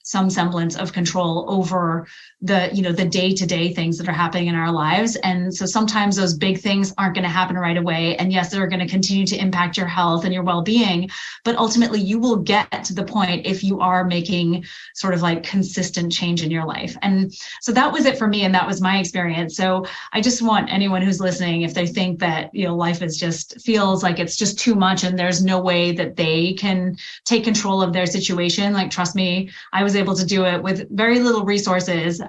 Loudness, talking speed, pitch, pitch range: -19 LUFS, 225 wpm, 185 Hz, 175-195 Hz